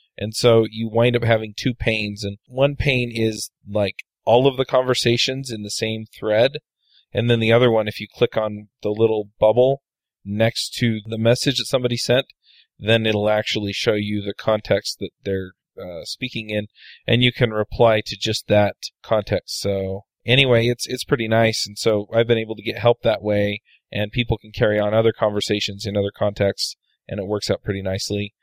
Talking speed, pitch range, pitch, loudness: 195 wpm, 105-120 Hz, 110 Hz, -20 LUFS